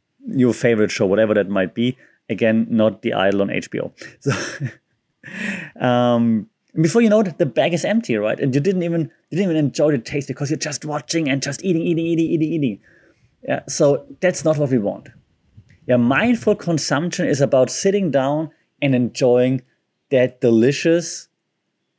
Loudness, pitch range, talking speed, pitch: -19 LUFS, 120-165 Hz, 175 wpm, 140 Hz